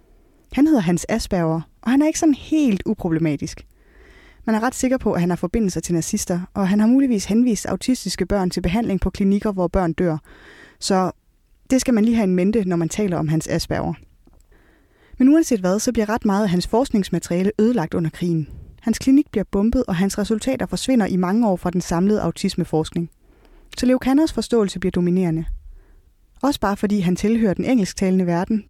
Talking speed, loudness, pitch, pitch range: 190 wpm, -20 LUFS, 200 Hz, 175-230 Hz